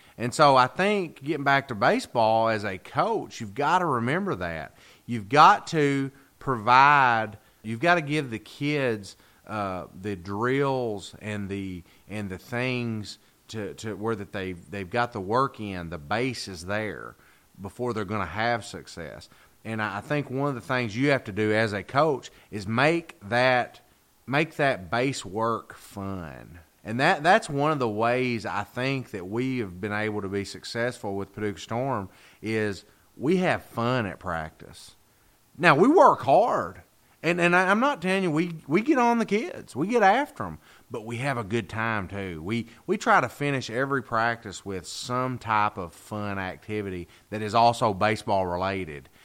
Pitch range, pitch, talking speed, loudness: 100-130 Hz, 110 Hz, 180 wpm, -25 LUFS